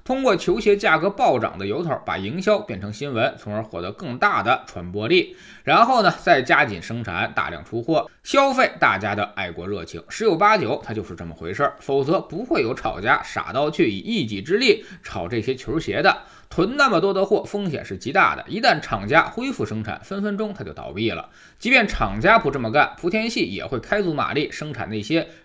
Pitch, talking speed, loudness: 135 Hz, 310 characters per minute, -21 LUFS